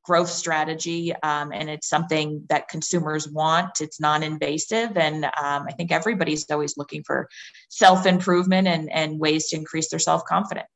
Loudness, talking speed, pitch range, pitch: -23 LUFS, 165 wpm, 150-170 Hz, 160 Hz